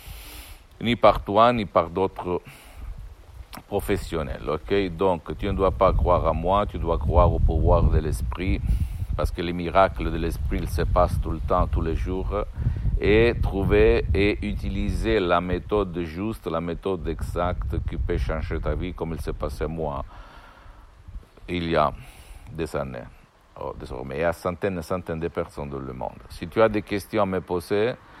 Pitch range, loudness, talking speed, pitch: 80-95 Hz, -25 LUFS, 180 wpm, 85 Hz